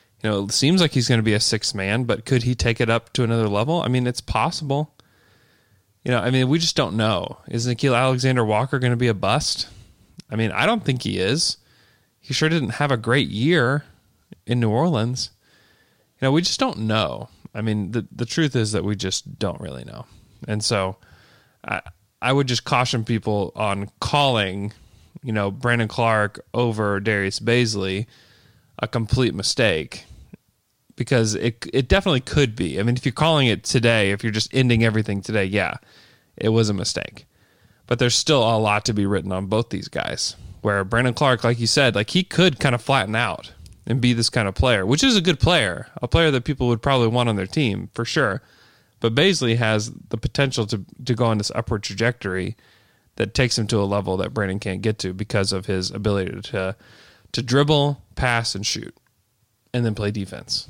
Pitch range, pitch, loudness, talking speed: 105-130 Hz, 115 Hz, -21 LUFS, 200 wpm